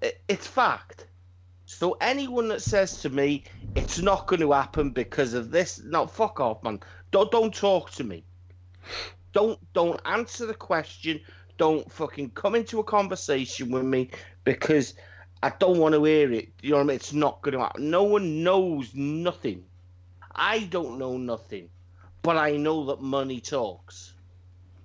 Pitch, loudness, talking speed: 140 Hz, -26 LUFS, 165 wpm